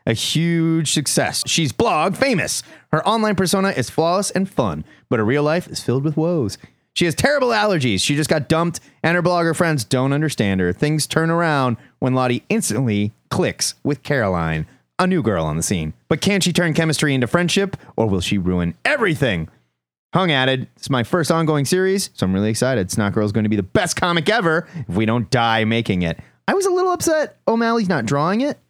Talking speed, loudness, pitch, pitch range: 205 wpm, -19 LUFS, 150 Hz, 115-175 Hz